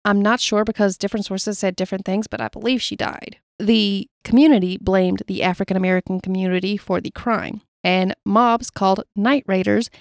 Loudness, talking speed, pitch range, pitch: -20 LUFS, 175 wpm, 185-220 Hz, 200 Hz